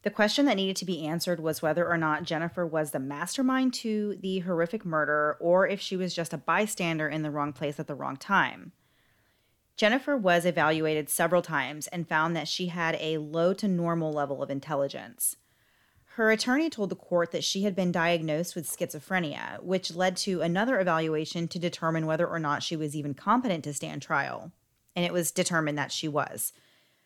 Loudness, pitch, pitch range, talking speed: -28 LUFS, 170 Hz, 155-185 Hz, 195 wpm